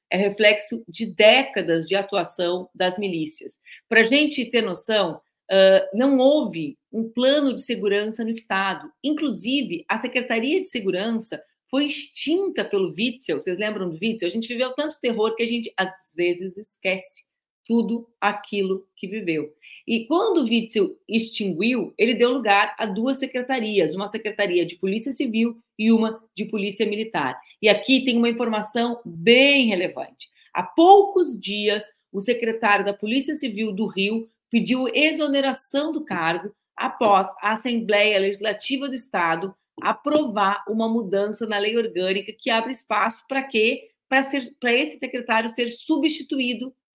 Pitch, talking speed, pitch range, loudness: 225 Hz, 145 wpm, 200-260 Hz, -22 LUFS